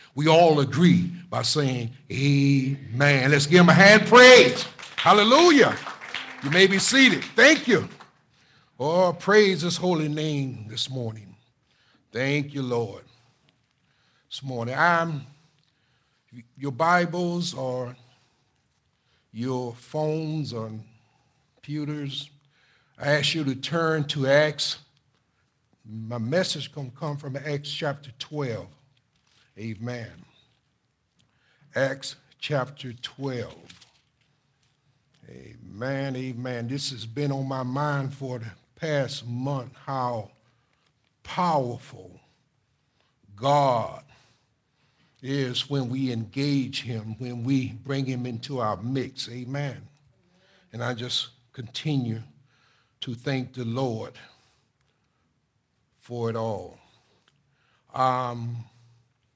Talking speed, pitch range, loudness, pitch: 100 wpm, 125-150 Hz, -23 LUFS, 135 Hz